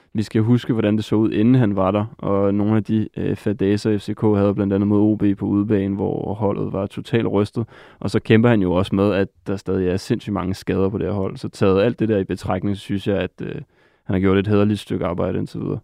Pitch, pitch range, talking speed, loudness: 100 Hz, 95-110 Hz, 260 wpm, -20 LUFS